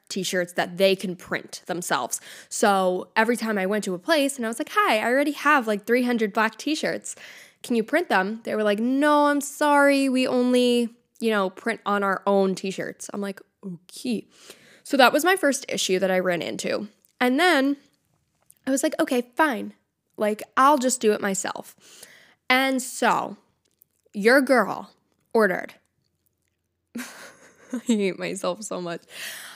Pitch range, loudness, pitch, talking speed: 195-275 Hz, -23 LUFS, 230 Hz, 170 wpm